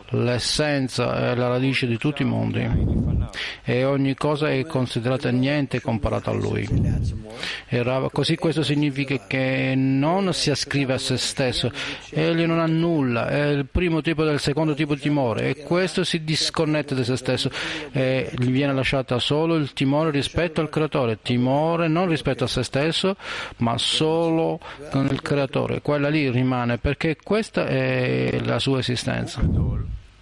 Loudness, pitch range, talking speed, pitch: -23 LUFS, 125-150 Hz, 155 wpm, 135 Hz